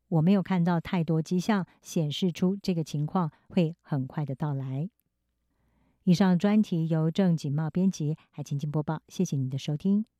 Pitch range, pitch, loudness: 150-185 Hz, 165 Hz, -28 LUFS